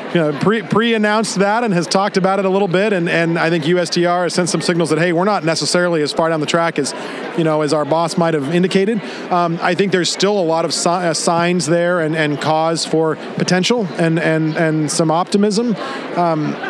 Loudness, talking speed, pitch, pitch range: -16 LUFS, 230 wpm, 175 Hz, 160-190 Hz